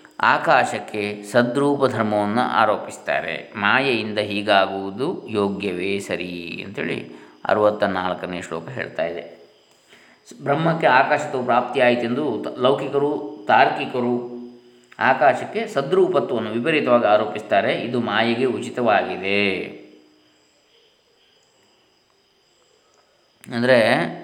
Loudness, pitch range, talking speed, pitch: -20 LUFS, 100-140 Hz, 70 wpm, 115 Hz